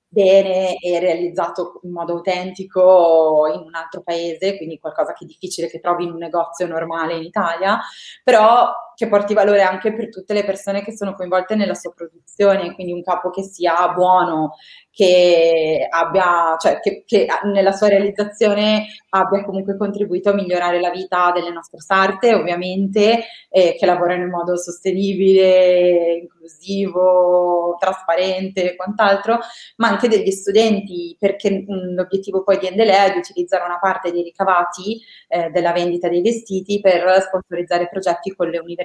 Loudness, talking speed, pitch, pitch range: -17 LUFS, 155 wpm, 185 Hz, 175-200 Hz